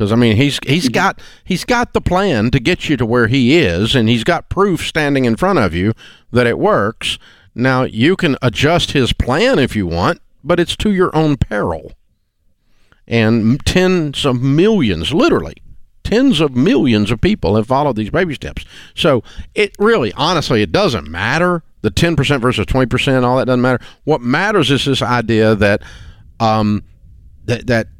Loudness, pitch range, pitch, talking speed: -14 LUFS, 110-155 Hz, 125 Hz, 180 wpm